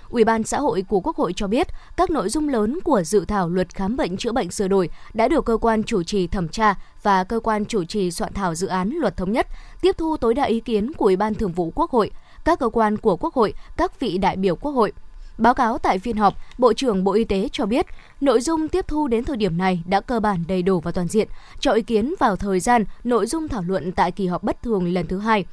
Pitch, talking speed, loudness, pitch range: 220 Hz, 270 wpm, -21 LUFS, 195-245 Hz